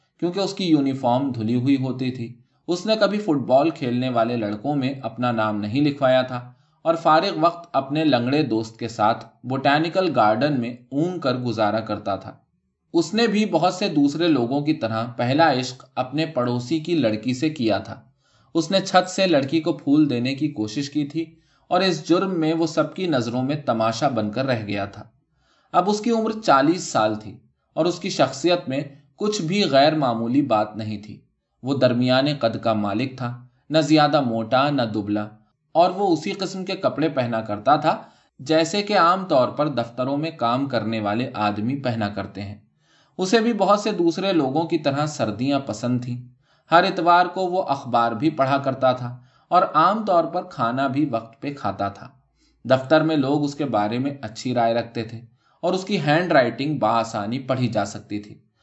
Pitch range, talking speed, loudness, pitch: 115-165 Hz, 190 wpm, -22 LUFS, 135 Hz